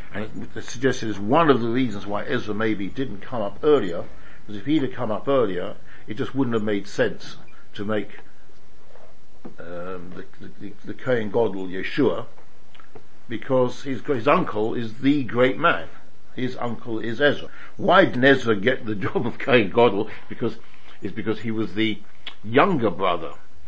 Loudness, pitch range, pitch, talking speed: -23 LUFS, 105-130 Hz, 115 Hz, 165 wpm